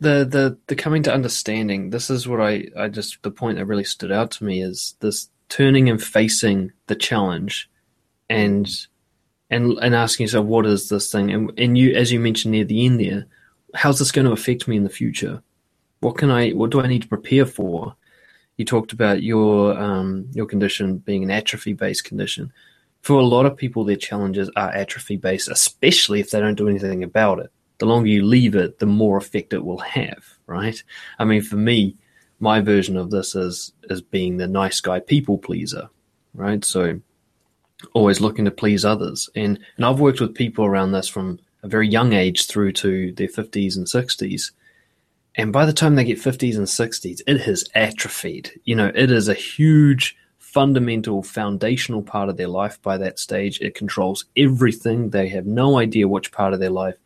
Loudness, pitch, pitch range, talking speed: -19 LUFS, 110 Hz, 100-120 Hz, 200 wpm